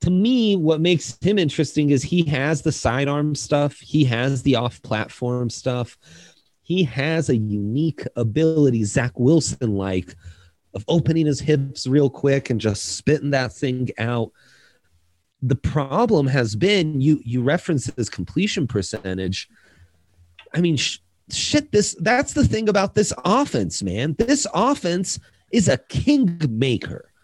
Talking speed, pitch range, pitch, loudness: 145 wpm, 115-165 Hz, 140 Hz, -21 LUFS